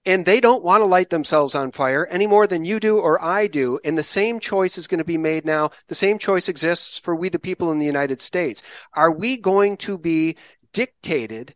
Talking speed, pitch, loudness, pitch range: 235 wpm, 175 Hz, -20 LUFS, 155-200 Hz